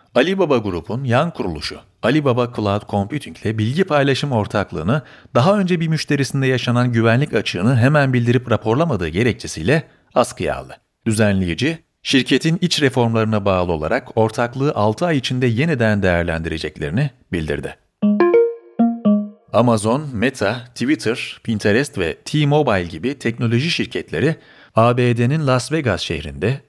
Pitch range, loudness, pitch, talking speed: 105-145 Hz, -18 LUFS, 120 Hz, 110 wpm